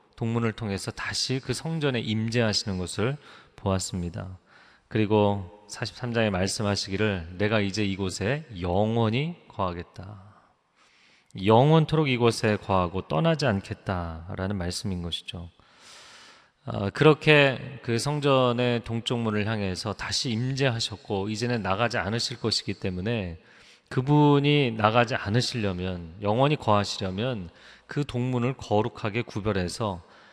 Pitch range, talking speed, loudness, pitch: 95-125 Hz, 280 characters per minute, -26 LUFS, 110 Hz